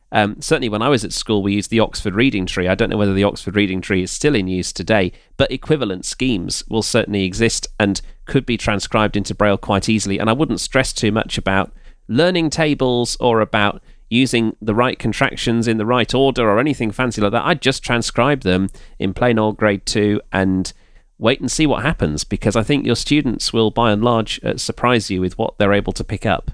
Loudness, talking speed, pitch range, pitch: -18 LUFS, 220 wpm, 100-125 Hz, 110 Hz